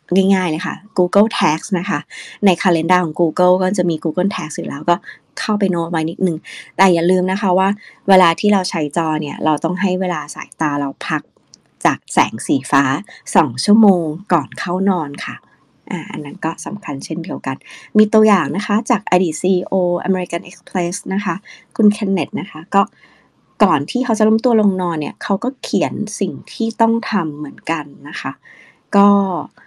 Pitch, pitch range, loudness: 185 Hz, 170-205 Hz, -17 LUFS